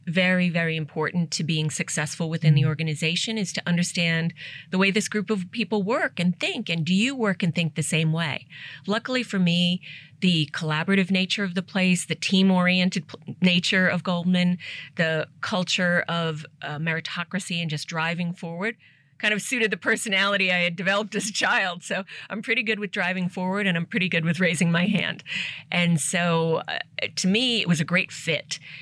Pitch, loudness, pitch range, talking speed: 180 Hz, -24 LUFS, 165-195 Hz, 185 wpm